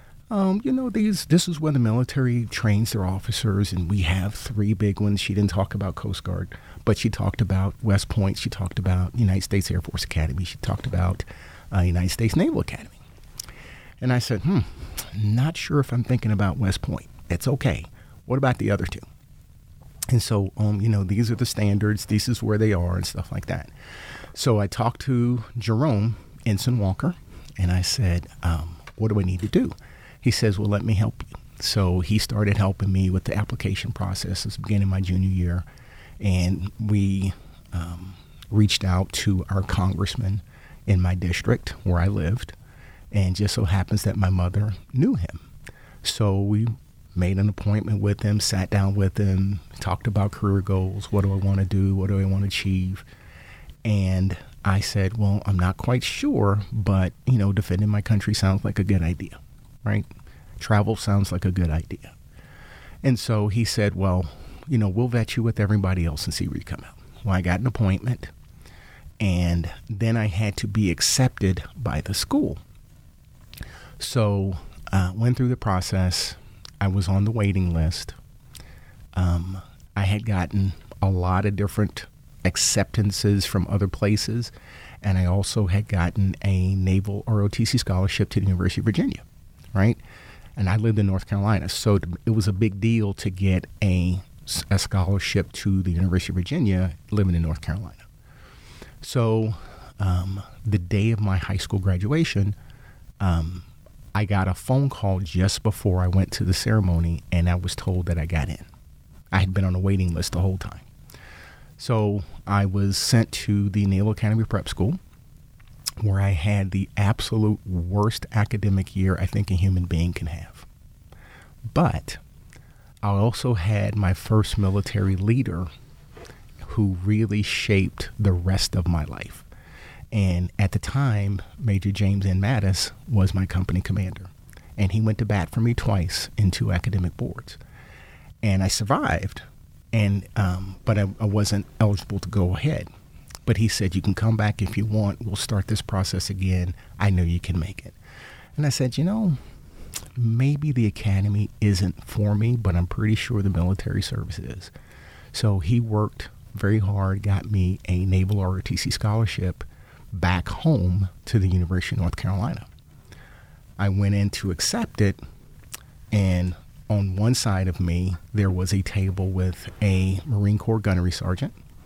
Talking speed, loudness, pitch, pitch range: 175 wpm, -24 LUFS, 100 Hz, 95-110 Hz